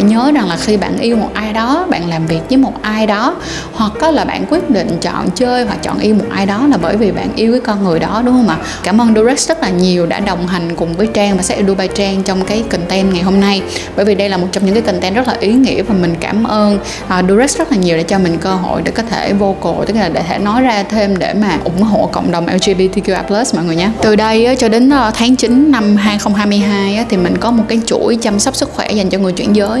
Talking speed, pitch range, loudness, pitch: 270 wpm, 190-230 Hz, -12 LUFS, 210 Hz